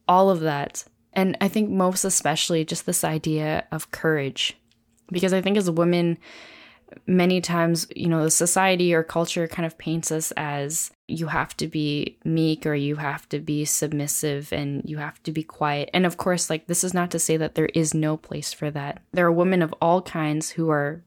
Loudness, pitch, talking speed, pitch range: -23 LUFS, 160 Hz, 205 wpm, 150-175 Hz